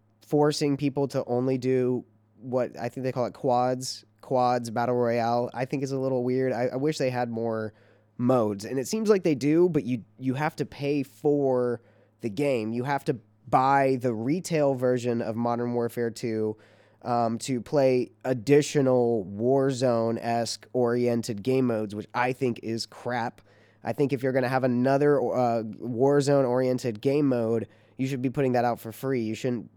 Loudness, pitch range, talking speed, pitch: -26 LUFS, 115-135 Hz, 185 wpm, 125 Hz